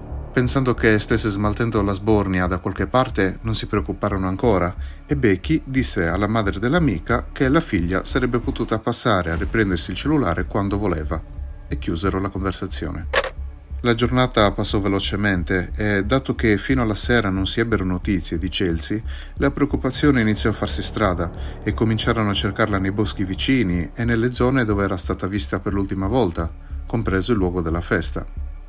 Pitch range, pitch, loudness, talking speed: 90-115 Hz, 100 Hz, -20 LUFS, 165 wpm